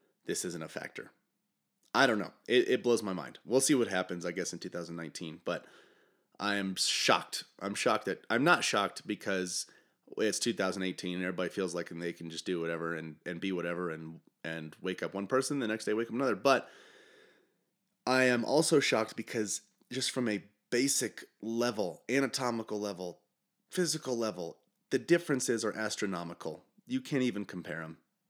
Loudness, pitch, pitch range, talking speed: -33 LUFS, 105 Hz, 90-125 Hz, 175 wpm